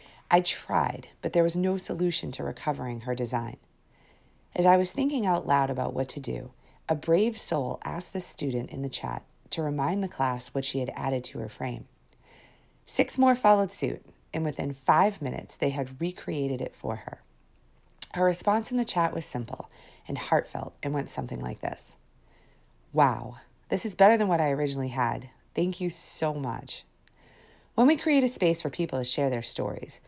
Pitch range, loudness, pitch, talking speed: 130-180 Hz, -28 LUFS, 155 Hz, 185 wpm